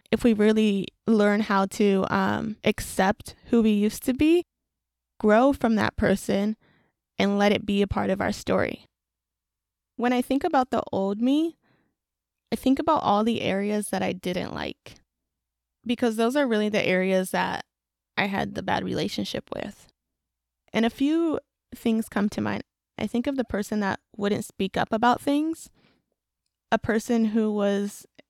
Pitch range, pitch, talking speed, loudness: 195-240 Hz, 210 Hz, 165 wpm, -25 LUFS